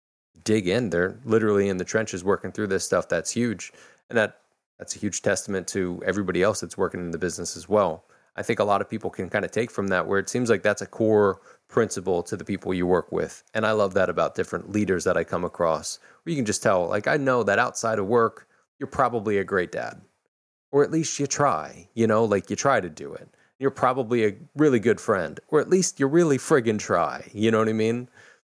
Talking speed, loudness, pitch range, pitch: 240 wpm, -24 LUFS, 95-120 Hz, 105 Hz